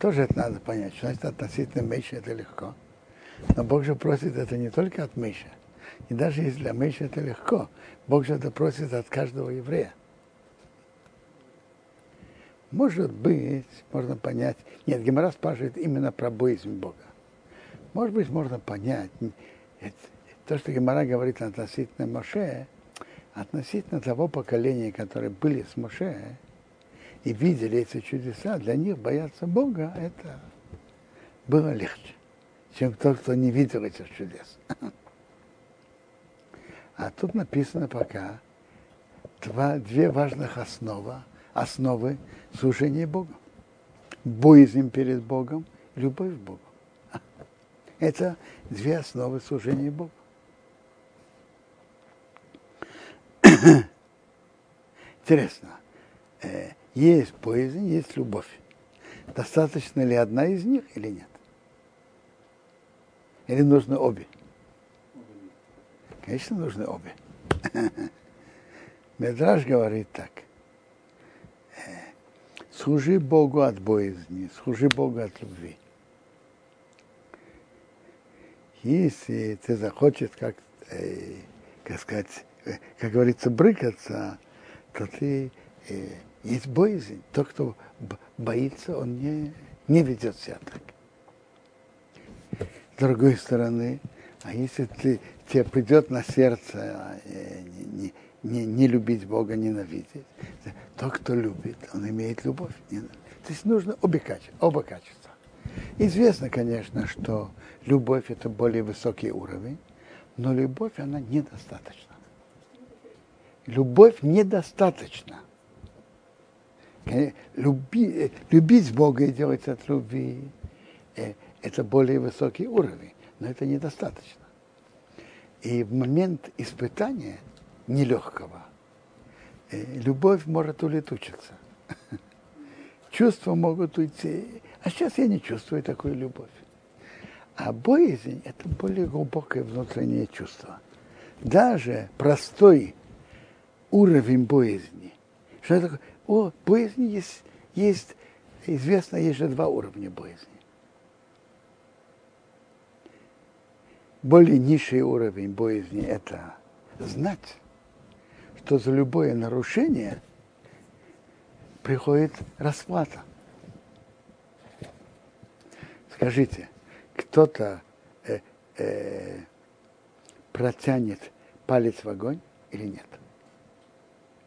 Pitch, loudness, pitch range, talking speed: 135 Hz, -25 LUFS, 120-155 Hz, 95 wpm